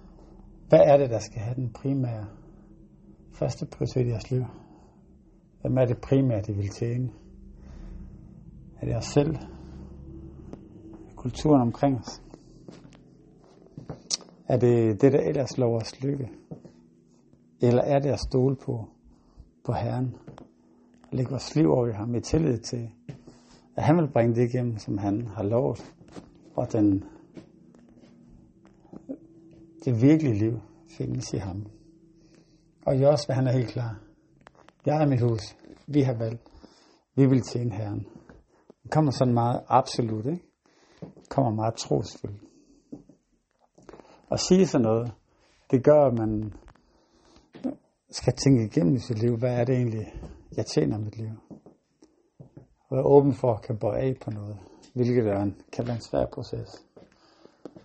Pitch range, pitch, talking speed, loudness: 105-135 Hz, 120 Hz, 145 wpm, -26 LUFS